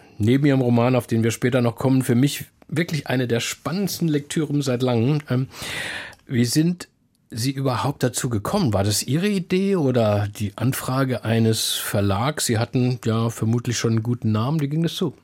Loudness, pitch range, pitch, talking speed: -22 LUFS, 115-145 Hz, 125 Hz, 175 wpm